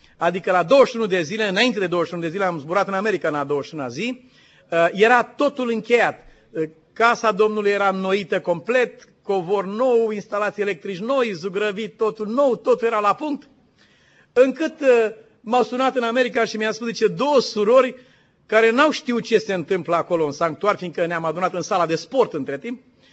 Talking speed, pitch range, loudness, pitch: 170 wpm, 185-240 Hz, -20 LUFS, 215 Hz